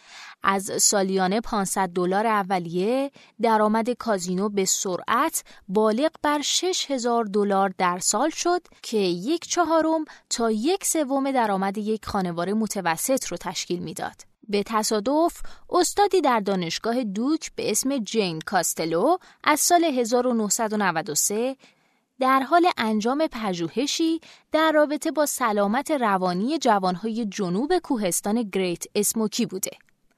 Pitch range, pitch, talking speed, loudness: 195-280 Hz, 225 Hz, 115 wpm, -23 LUFS